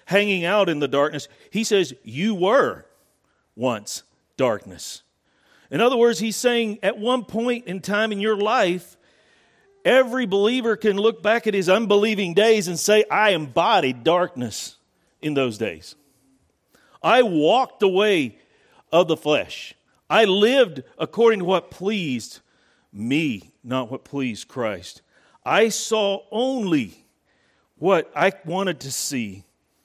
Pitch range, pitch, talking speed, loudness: 150-220 Hz, 195 Hz, 135 wpm, -21 LUFS